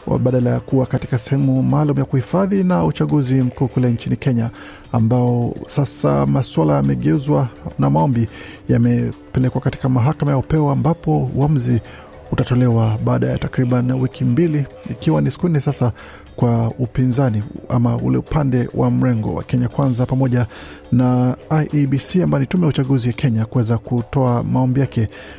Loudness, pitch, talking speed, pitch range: -18 LUFS, 125 Hz, 145 wpm, 115-140 Hz